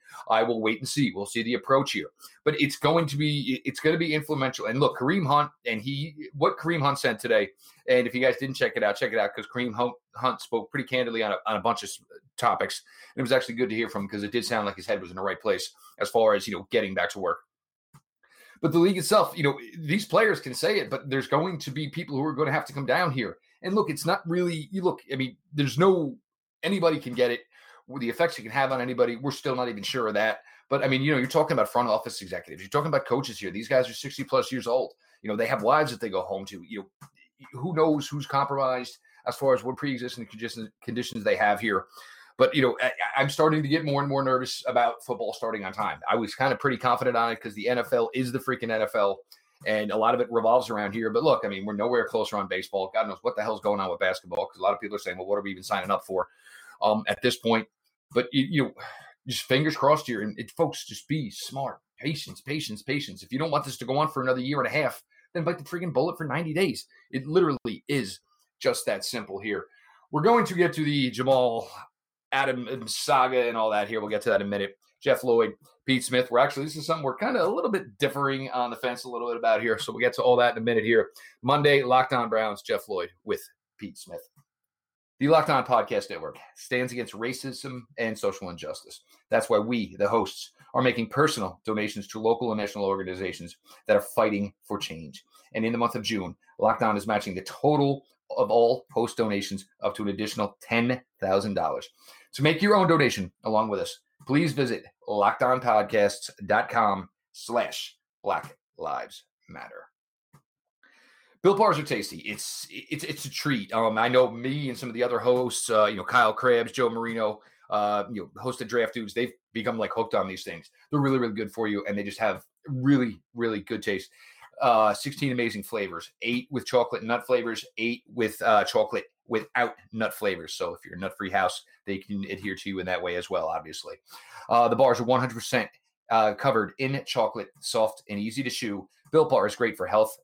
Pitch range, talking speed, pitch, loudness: 110-150 Hz, 235 wpm, 125 Hz, -27 LUFS